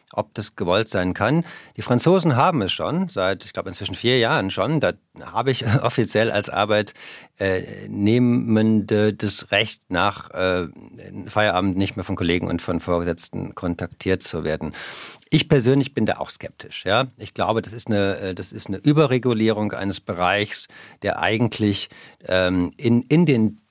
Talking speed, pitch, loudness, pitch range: 160 wpm, 105 Hz, -21 LUFS, 95-120 Hz